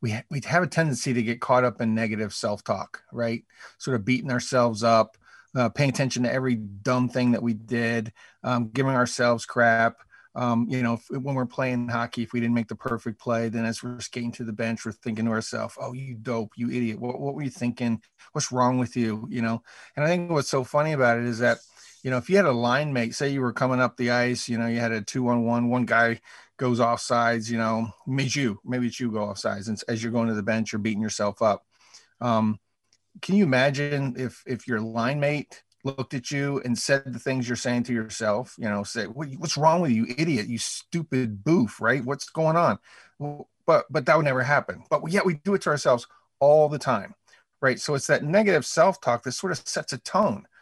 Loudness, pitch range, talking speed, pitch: -25 LUFS, 115-130 Hz, 235 wpm, 120 Hz